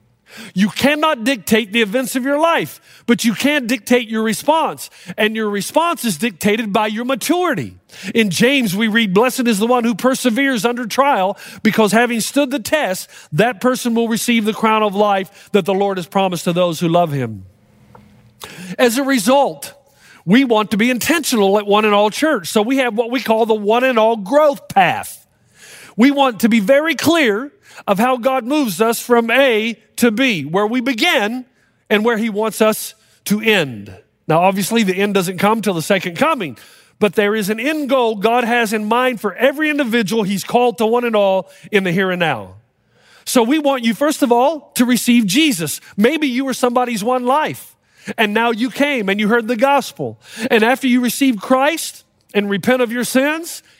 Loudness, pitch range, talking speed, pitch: -16 LUFS, 205-260 Hz, 195 wpm, 230 Hz